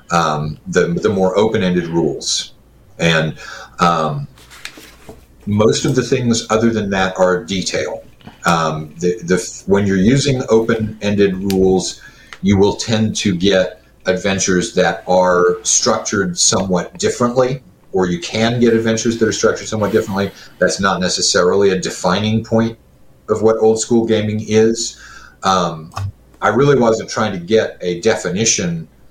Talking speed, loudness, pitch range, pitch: 145 wpm, -16 LUFS, 90-110 Hz, 100 Hz